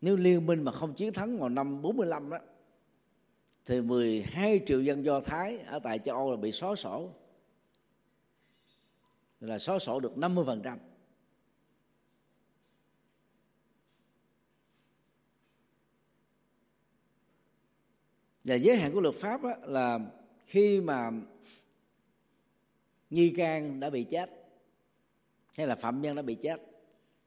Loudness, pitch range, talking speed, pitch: -31 LUFS, 135-190 Hz, 110 wpm, 160 Hz